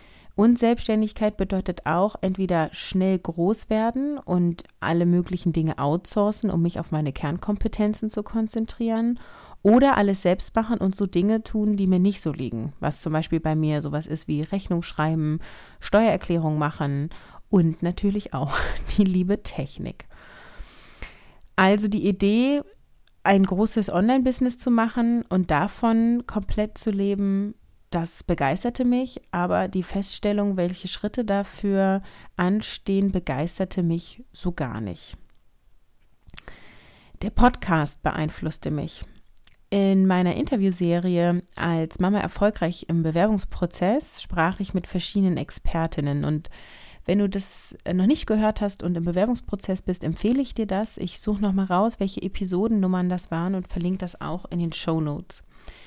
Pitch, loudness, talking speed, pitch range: 190 Hz, -24 LUFS, 135 wpm, 170-210 Hz